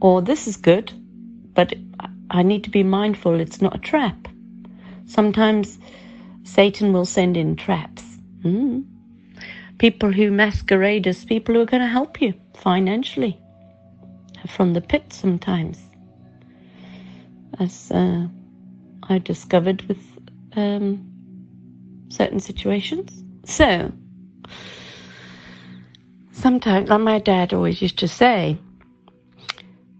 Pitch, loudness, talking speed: 185 Hz, -20 LUFS, 110 wpm